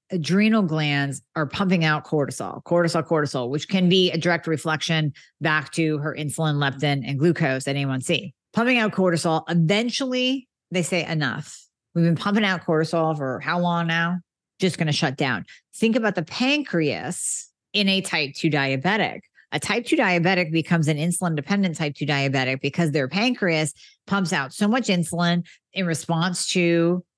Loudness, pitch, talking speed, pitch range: -22 LUFS, 170 Hz, 170 wpm, 150-185 Hz